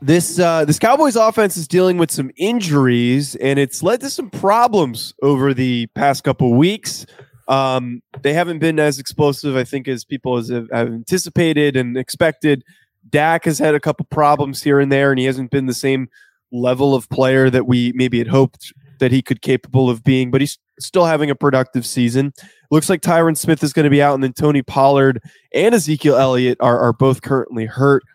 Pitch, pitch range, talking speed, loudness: 140 Hz, 130-155 Hz, 200 wpm, -16 LUFS